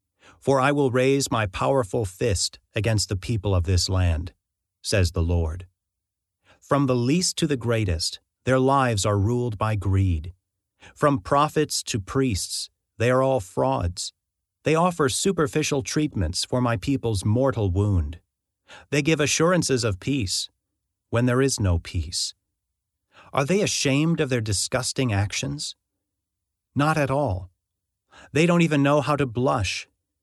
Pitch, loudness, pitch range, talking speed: 110 Hz, -23 LUFS, 95-135 Hz, 145 wpm